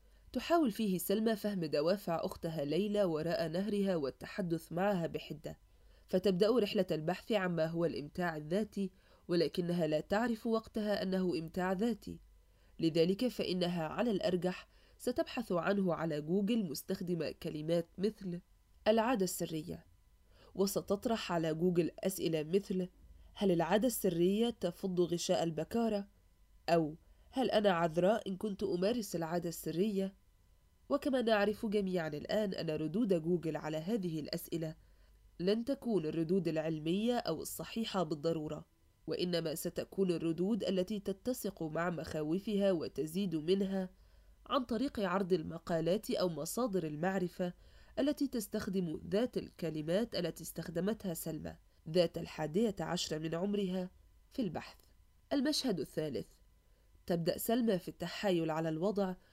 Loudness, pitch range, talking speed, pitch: -36 LUFS, 160-205 Hz, 115 wpm, 180 Hz